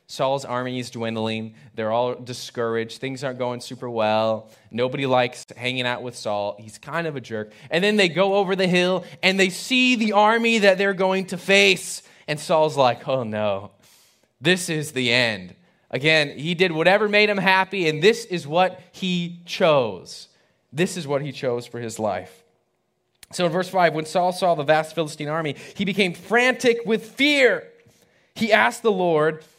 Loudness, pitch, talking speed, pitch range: -21 LUFS, 160 Hz, 185 wpm, 125-190 Hz